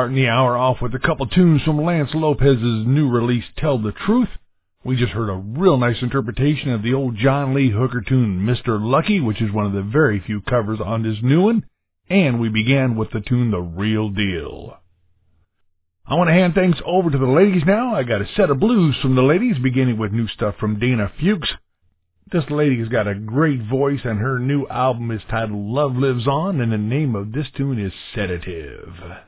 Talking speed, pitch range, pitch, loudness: 210 wpm, 110-140 Hz, 125 Hz, -19 LUFS